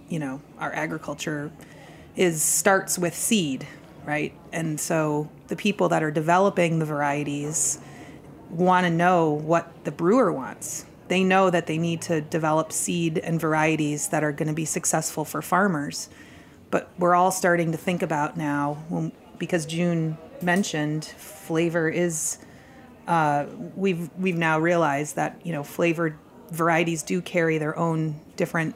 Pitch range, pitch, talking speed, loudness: 155-175 Hz, 165 Hz, 150 wpm, -24 LUFS